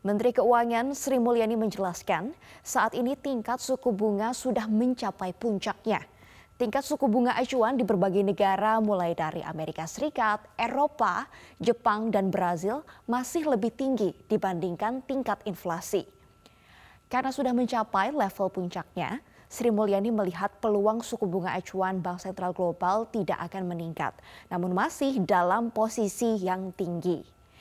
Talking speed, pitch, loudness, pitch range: 125 wpm, 215 Hz, -28 LUFS, 185-245 Hz